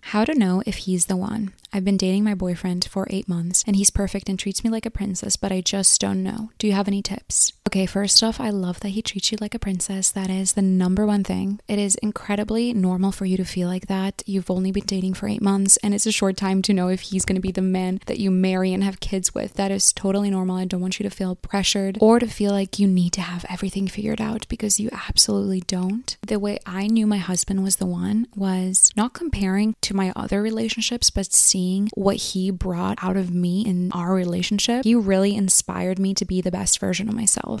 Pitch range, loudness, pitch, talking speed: 185-210 Hz, -21 LUFS, 195 Hz, 245 wpm